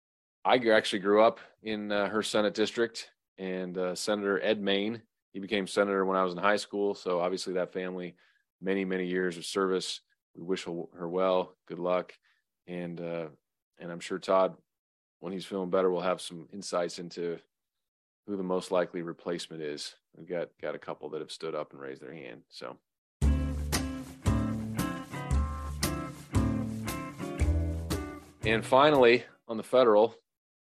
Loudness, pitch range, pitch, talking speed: -30 LUFS, 85-105 Hz, 95 Hz, 150 wpm